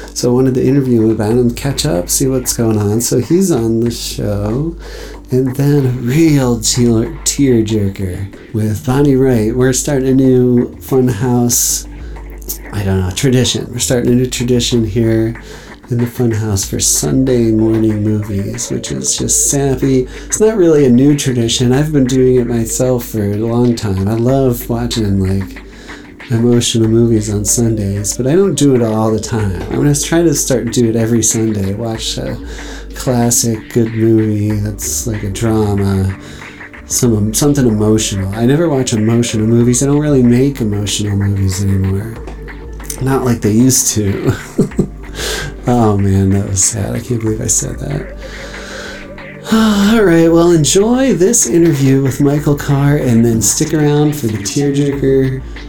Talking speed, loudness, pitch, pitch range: 165 wpm, -13 LUFS, 120 Hz, 110-135 Hz